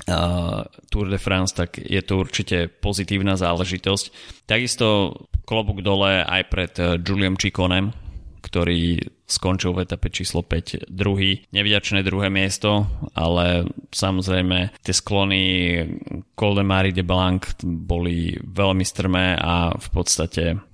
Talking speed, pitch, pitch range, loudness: 120 wpm, 95 Hz, 85-100 Hz, -21 LUFS